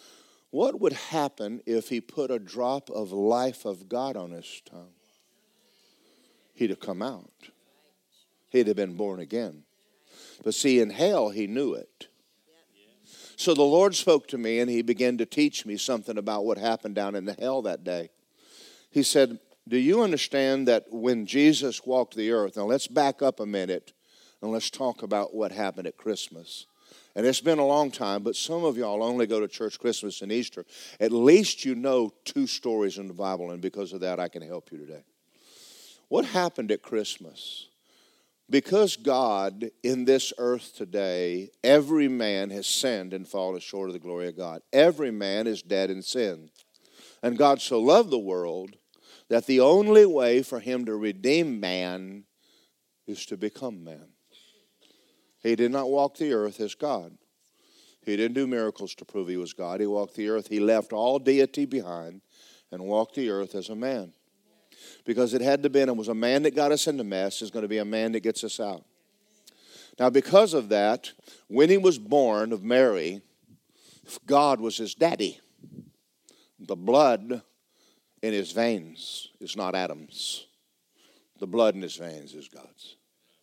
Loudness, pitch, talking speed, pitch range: -26 LUFS, 115 Hz, 180 wpm, 100-135 Hz